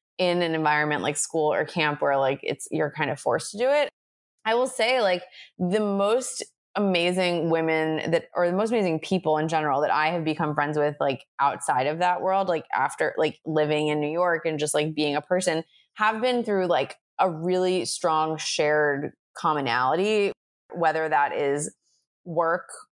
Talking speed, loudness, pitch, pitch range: 185 wpm, -25 LUFS, 160 Hz, 150-185 Hz